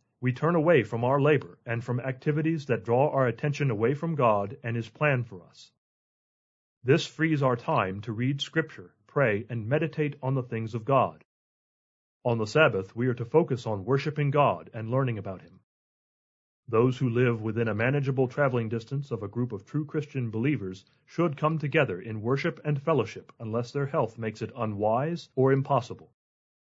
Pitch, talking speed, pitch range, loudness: 130 Hz, 180 wpm, 115-145 Hz, -28 LUFS